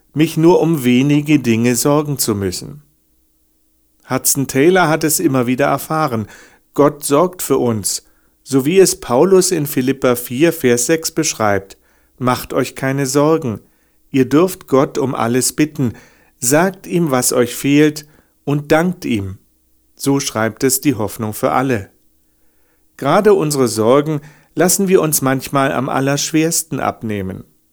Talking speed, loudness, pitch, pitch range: 140 wpm, -15 LUFS, 135 Hz, 115-155 Hz